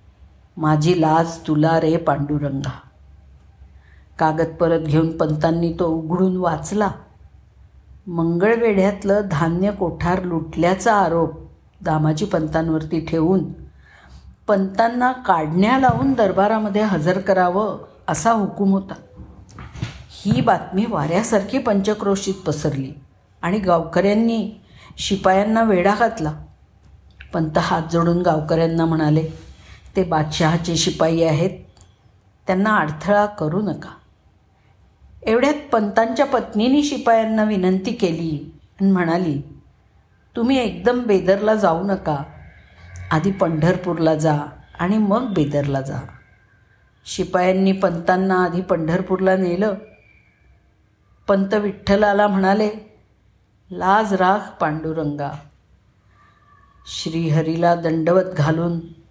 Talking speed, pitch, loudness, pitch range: 85 wpm, 170 Hz, -19 LUFS, 150-200 Hz